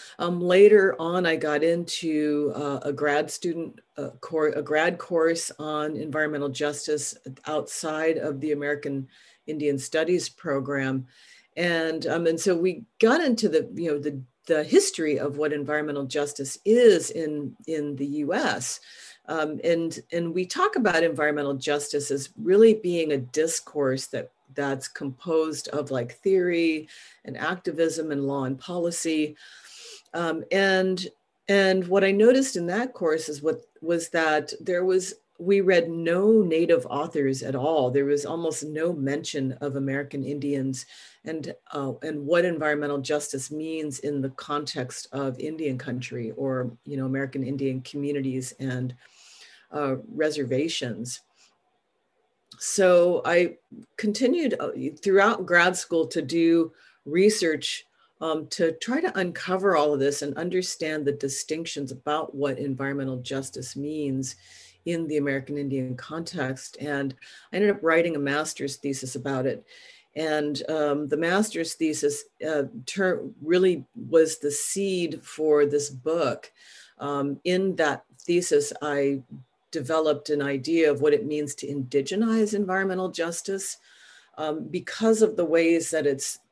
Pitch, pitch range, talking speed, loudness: 155 Hz, 140-170 Hz, 140 wpm, -25 LUFS